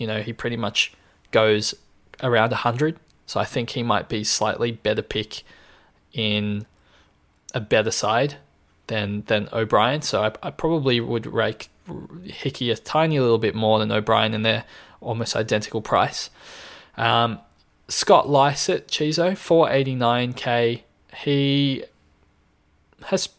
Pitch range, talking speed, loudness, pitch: 110-140 Hz, 135 wpm, -22 LUFS, 115 Hz